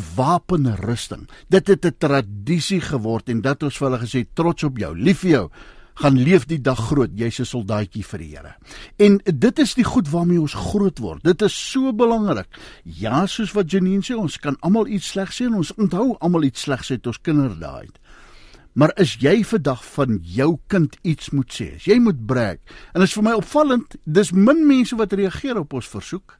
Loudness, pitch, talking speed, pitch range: -19 LUFS, 165 Hz, 200 wpm, 130-200 Hz